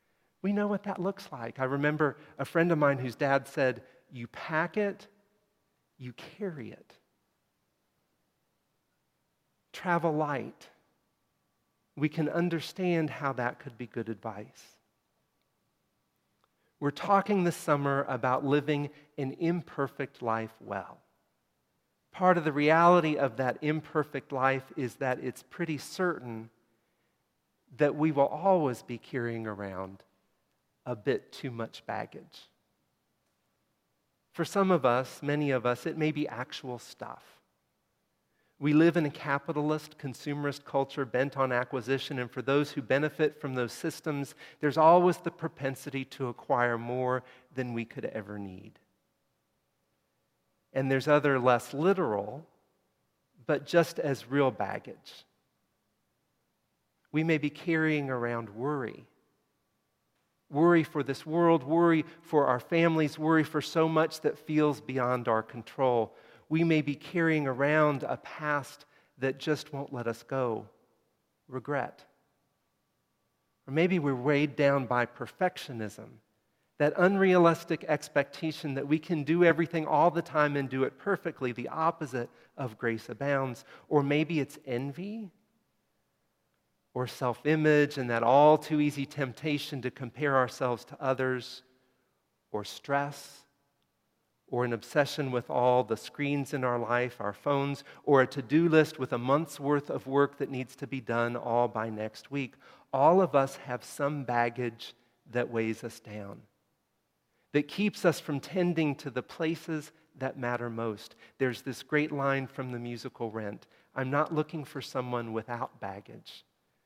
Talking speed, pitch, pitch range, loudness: 140 wpm, 140 Hz, 125-155 Hz, -30 LUFS